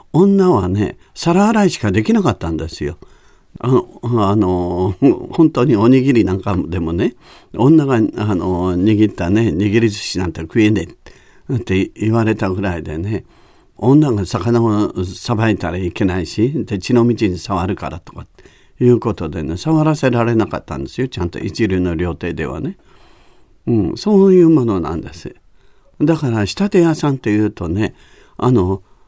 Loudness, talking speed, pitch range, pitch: -16 LUFS, 305 characters per minute, 90-125 Hz, 105 Hz